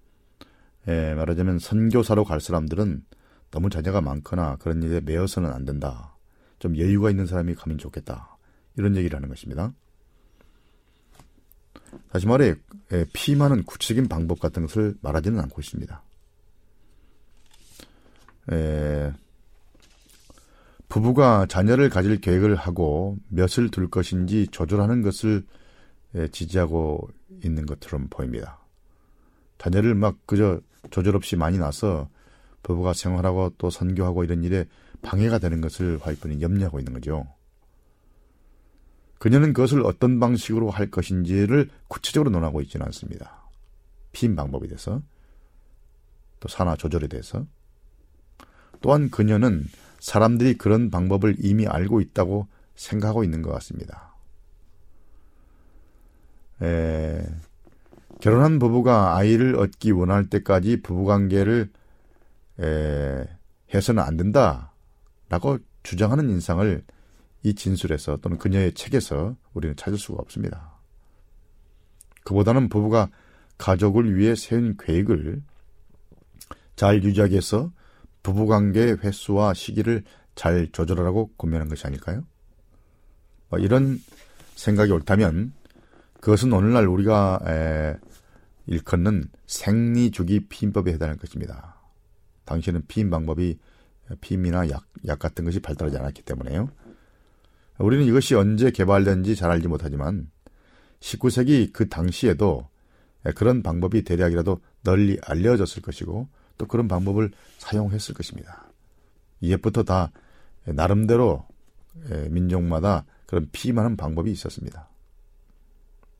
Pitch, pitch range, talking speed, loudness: 95 Hz, 80-105 Hz, 270 characters per minute, -23 LUFS